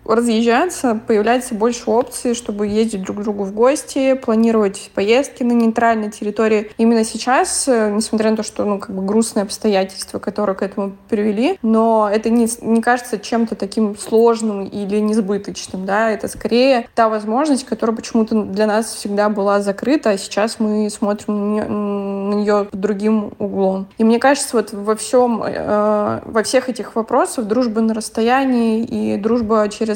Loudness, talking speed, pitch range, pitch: -17 LUFS, 160 wpm, 210-235 Hz, 220 Hz